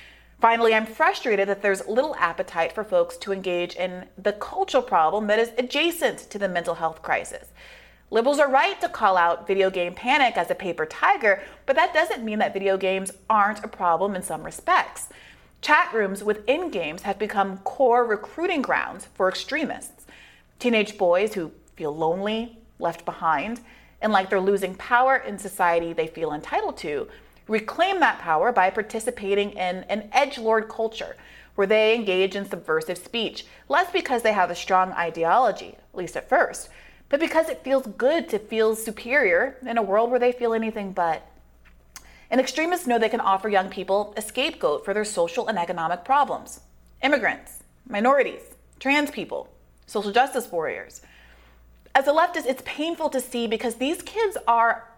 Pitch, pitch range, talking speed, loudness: 215 Hz, 185-250 Hz, 170 wpm, -23 LUFS